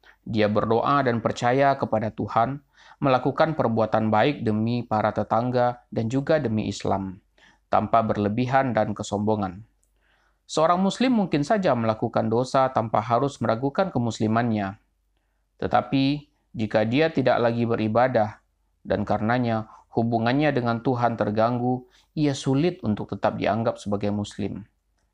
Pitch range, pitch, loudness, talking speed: 105-135 Hz, 115 Hz, -24 LUFS, 115 wpm